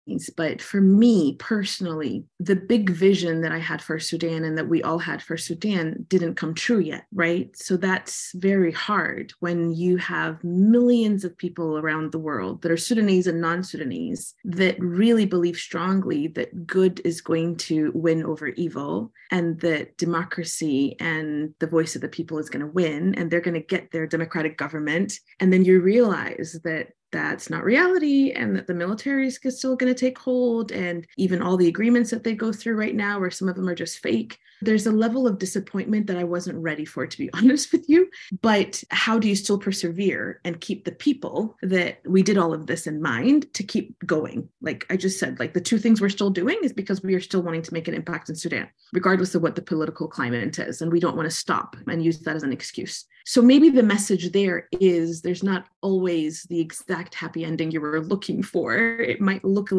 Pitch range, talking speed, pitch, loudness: 165-205 Hz, 210 wpm, 180 Hz, -23 LUFS